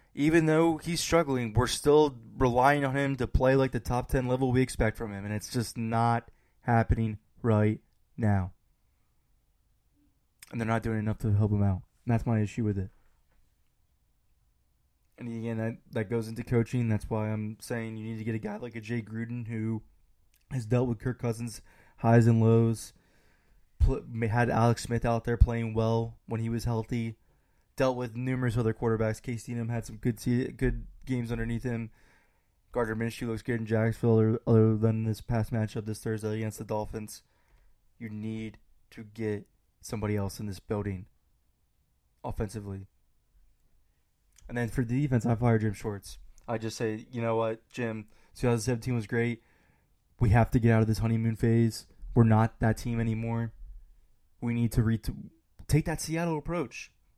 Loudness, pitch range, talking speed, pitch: -29 LUFS, 110-120 Hz, 175 wpm, 115 Hz